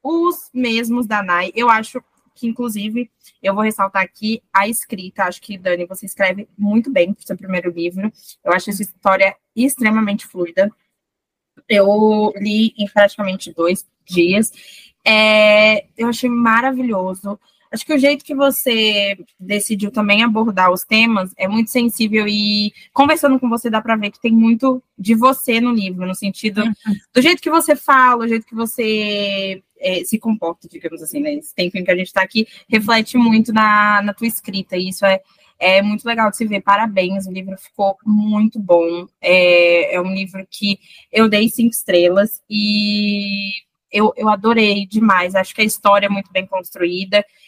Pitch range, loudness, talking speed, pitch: 195-230 Hz, -16 LUFS, 170 wpm, 210 Hz